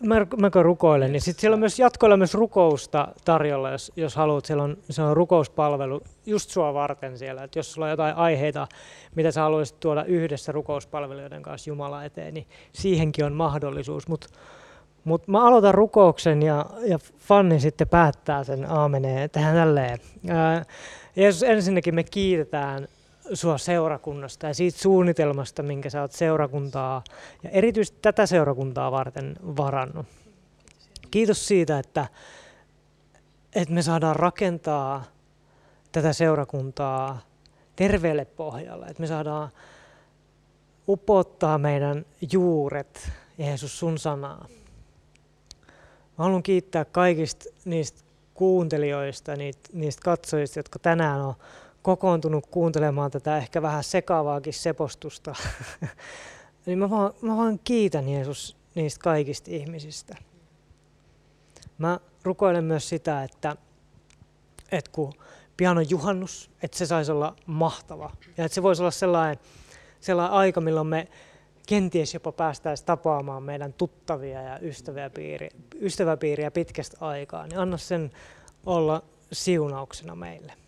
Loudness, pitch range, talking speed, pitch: -24 LUFS, 145-175 Hz, 125 wpm, 155 Hz